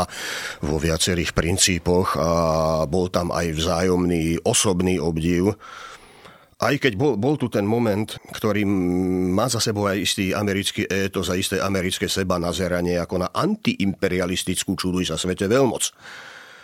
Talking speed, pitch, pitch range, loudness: 135 wpm, 95 Hz, 90-105 Hz, -22 LUFS